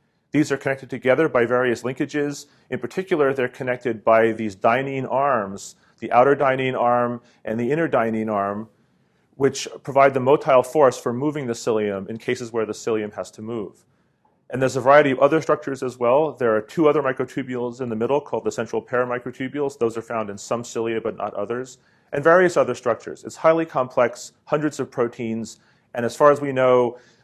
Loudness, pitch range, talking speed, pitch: -21 LUFS, 115-135 Hz, 190 wpm, 125 Hz